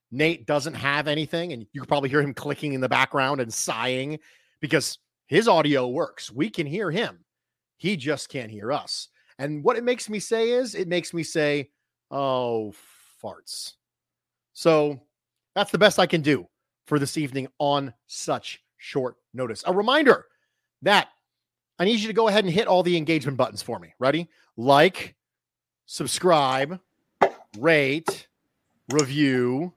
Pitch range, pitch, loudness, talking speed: 130-170 Hz, 145 Hz, -24 LUFS, 155 wpm